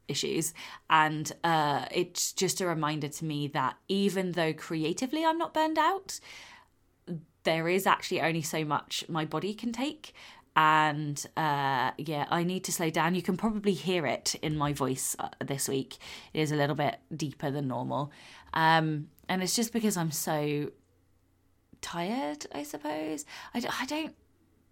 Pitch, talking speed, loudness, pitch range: 160 Hz, 165 wpm, -30 LUFS, 145-185 Hz